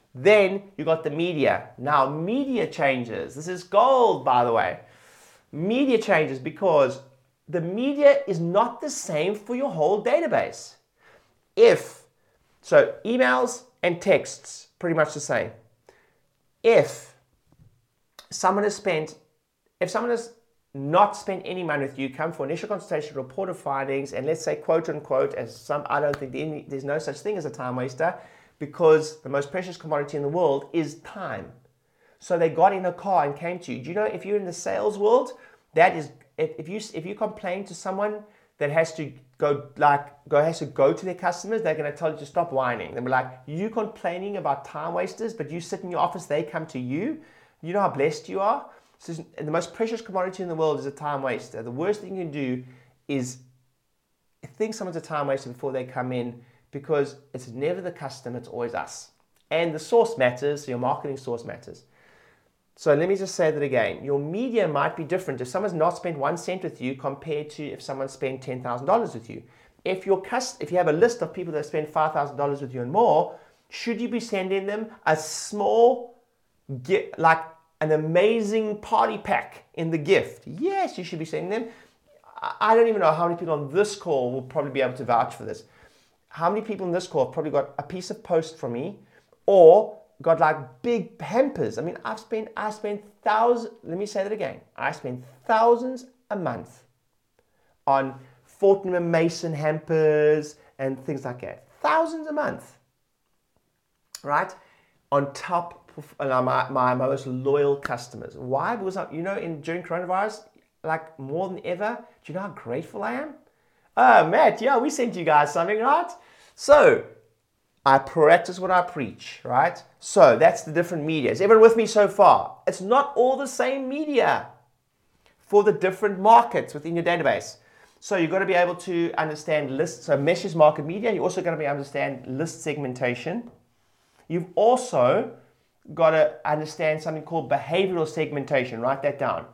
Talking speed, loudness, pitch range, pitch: 190 wpm, -24 LUFS, 145-205 Hz, 165 Hz